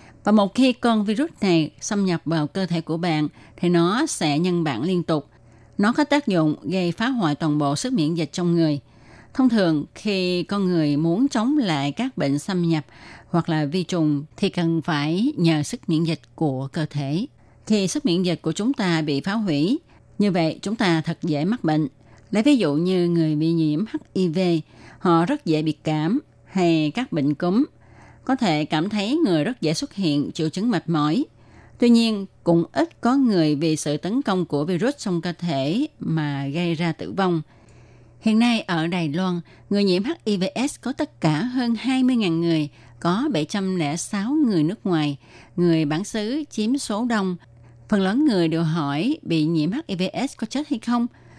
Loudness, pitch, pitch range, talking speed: -22 LUFS, 170 Hz, 155-215 Hz, 195 wpm